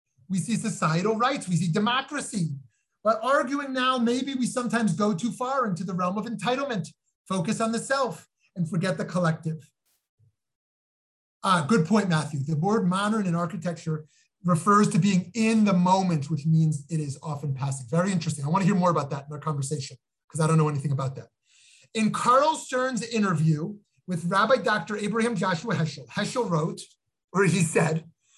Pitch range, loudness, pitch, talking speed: 160-220 Hz, -26 LUFS, 185 Hz, 180 wpm